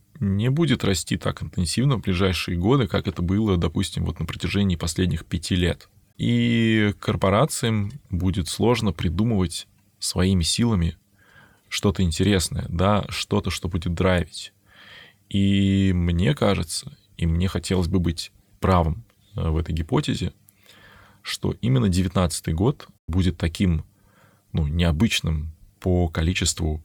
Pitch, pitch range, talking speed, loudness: 95 Hz, 90-105 Hz, 120 wpm, -23 LUFS